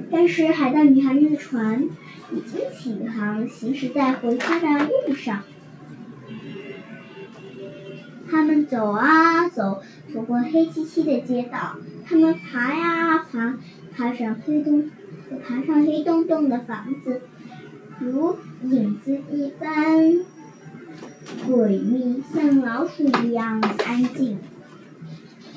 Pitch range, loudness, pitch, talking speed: 240-315 Hz, -21 LUFS, 270 Hz, 155 characters per minute